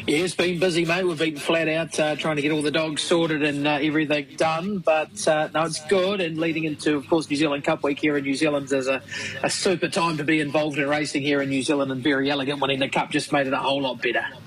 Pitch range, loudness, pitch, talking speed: 145-165 Hz, -23 LUFS, 155 Hz, 275 wpm